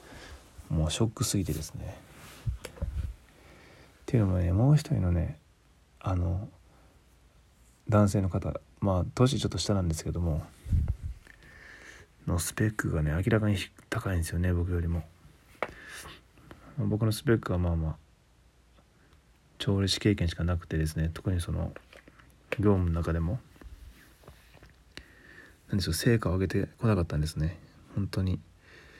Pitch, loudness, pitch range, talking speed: 90 Hz, -30 LUFS, 80-105 Hz, 260 characters per minute